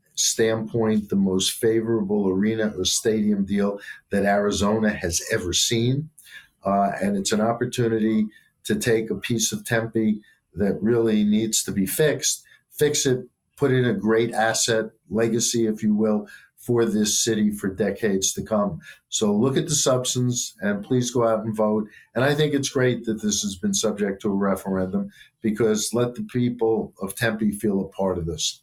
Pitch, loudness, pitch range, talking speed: 110 Hz, -23 LUFS, 105-125 Hz, 175 wpm